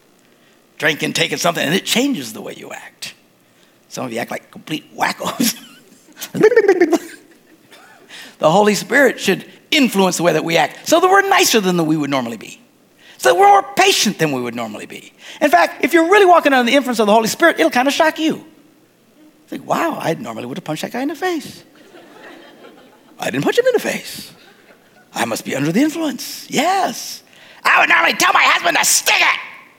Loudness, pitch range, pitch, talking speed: -15 LUFS, 210-340 Hz, 285 Hz, 200 wpm